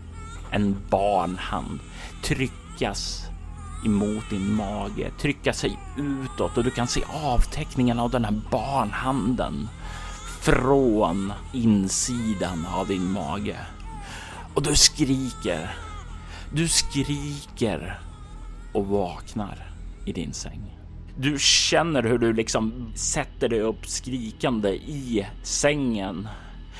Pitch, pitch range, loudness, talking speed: 105 Hz, 85-125 Hz, -25 LUFS, 100 wpm